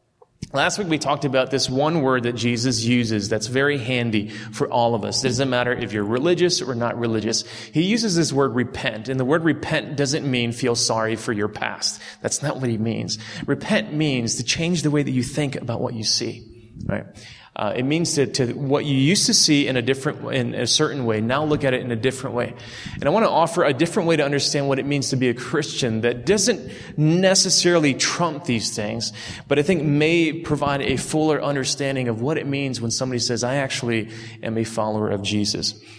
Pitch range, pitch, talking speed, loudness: 115-150 Hz, 130 Hz, 220 wpm, -21 LUFS